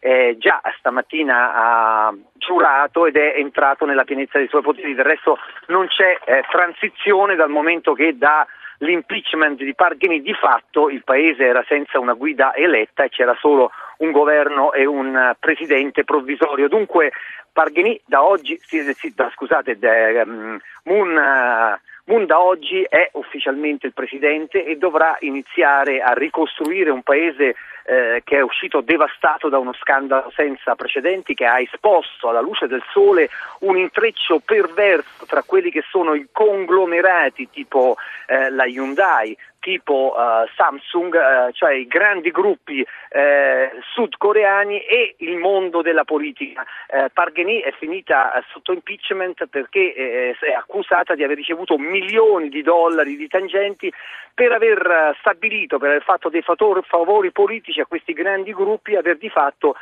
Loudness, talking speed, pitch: -17 LUFS, 150 wpm, 175 Hz